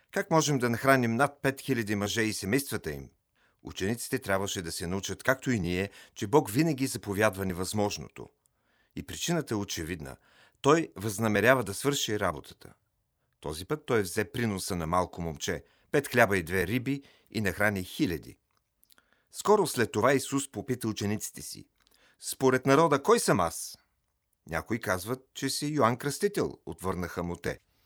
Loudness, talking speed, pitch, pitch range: -29 LUFS, 150 wpm, 110 Hz, 95-135 Hz